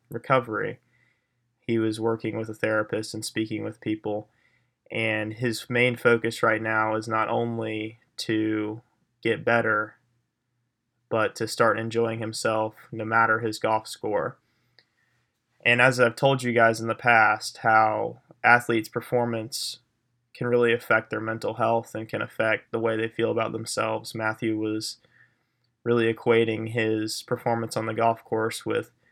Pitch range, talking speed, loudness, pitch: 110-120 Hz, 145 wpm, -25 LUFS, 115 Hz